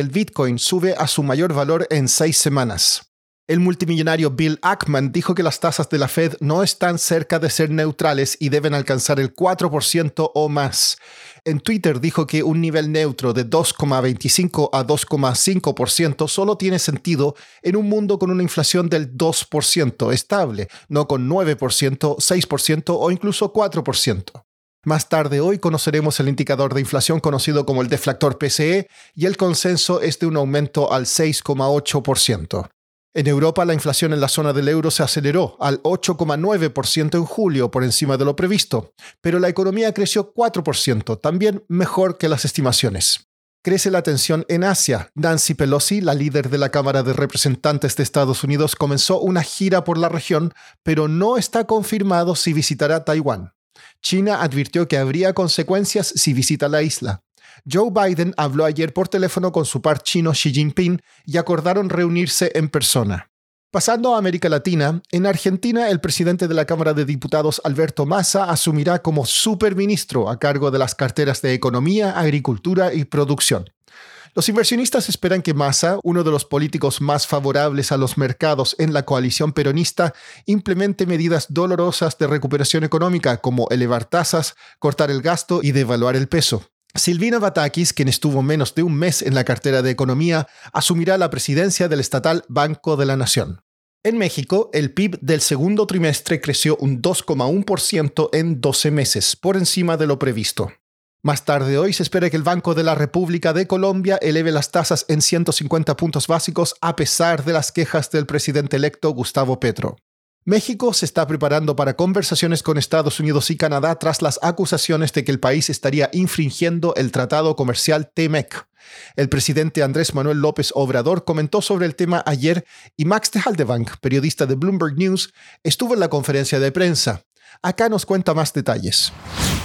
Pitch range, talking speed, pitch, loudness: 140-175 Hz, 165 wpm, 155 Hz, -18 LUFS